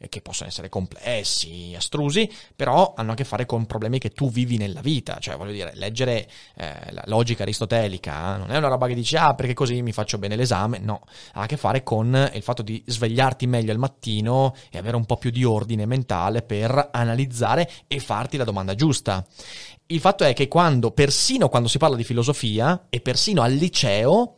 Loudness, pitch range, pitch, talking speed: -22 LUFS, 110-135 Hz, 120 Hz, 200 wpm